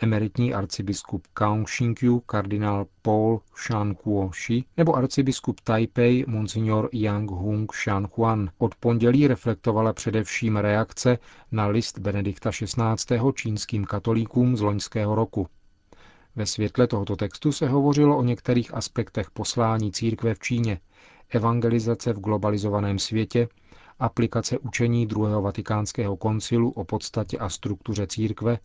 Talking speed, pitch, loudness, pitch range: 115 wpm, 110 Hz, -25 LUFS, 105-120 Hz